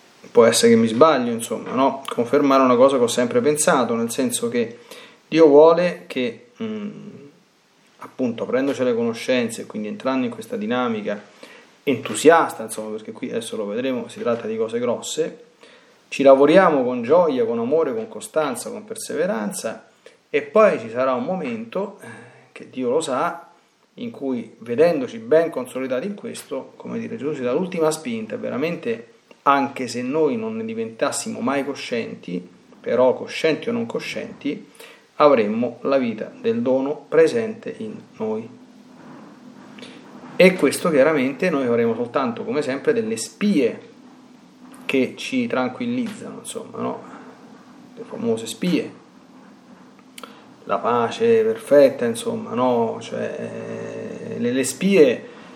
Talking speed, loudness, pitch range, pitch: 135 wpm, -20 LUFS, 155-240 Hz, 230 Hz